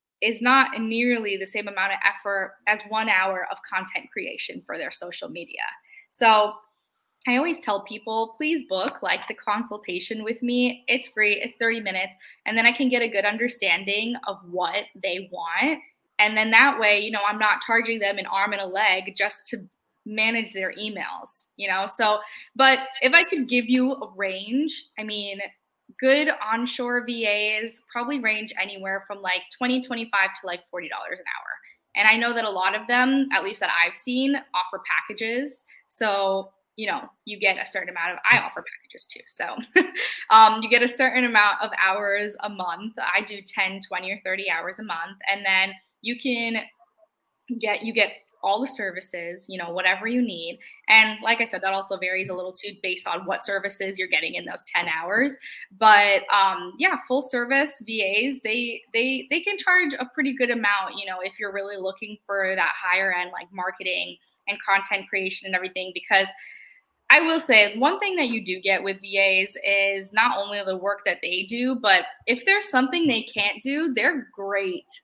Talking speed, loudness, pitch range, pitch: 195 wpm, -22 LUFS, 195-245 Hz, 215 Hz